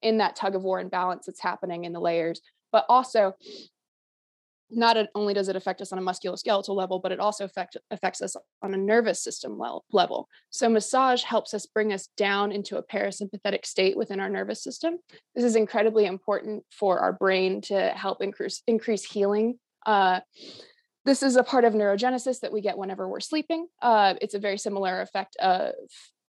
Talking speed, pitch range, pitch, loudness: 185 wpm, 190-235 Hz, 205 Hz, -26 LUFS